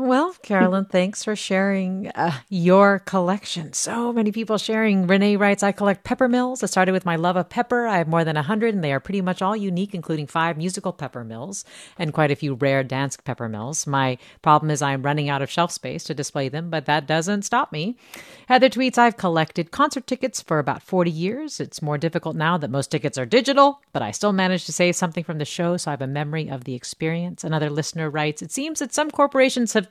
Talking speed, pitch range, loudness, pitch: 225 wpm, 150-215 Hz, -22 LUFS, 180 Hz